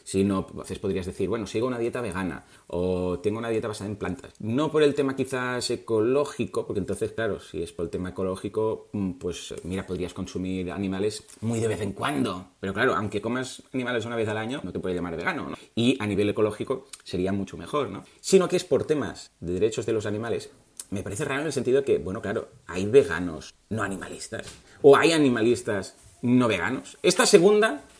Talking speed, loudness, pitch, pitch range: 205 wpm, -26 LUFS, 110 Hz, 95-130 Hz